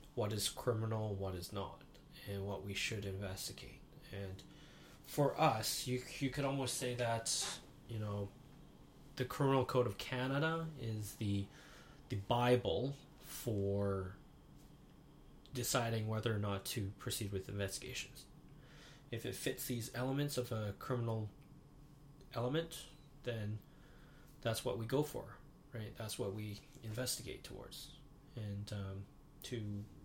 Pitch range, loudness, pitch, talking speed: 105-140 Hz, -41 LUFS, 125 Hz, 130 wpm